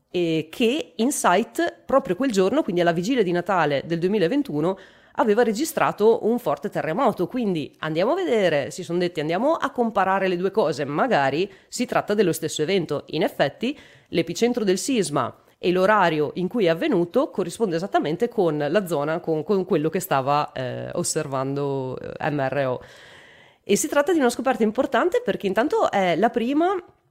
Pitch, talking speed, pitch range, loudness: 190 Hz, 160 wpm, 160-235 Hz, -23 LUFS